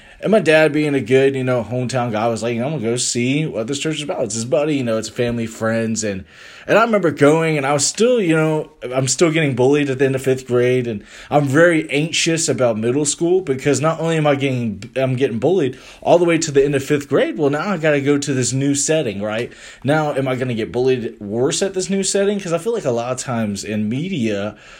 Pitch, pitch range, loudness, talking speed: 135 Hz, 120-155 Hz, -18 LUFS, 255 wpm